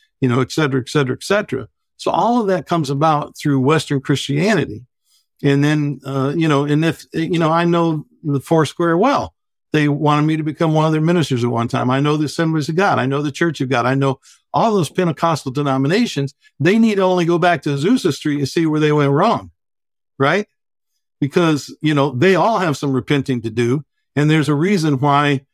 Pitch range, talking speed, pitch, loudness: 135-165 Hz, 220 wpm, 150 Hz, -17 LUFS